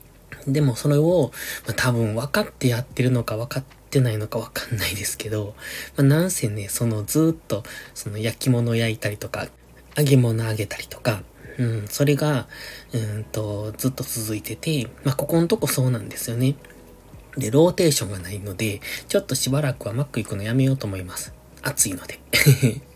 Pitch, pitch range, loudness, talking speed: 120 Hz, 110-140 Hz, -23 LUFS, 365 characters per minute